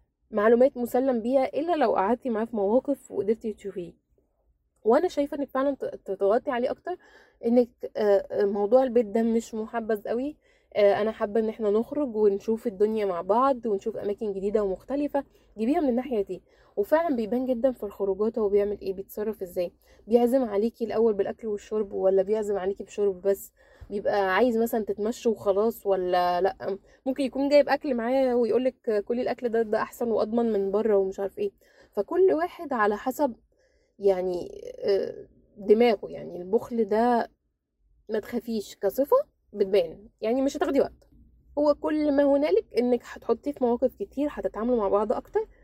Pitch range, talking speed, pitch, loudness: 205-270 Hz, 155 wpm, 230 Hz, -26 LUFS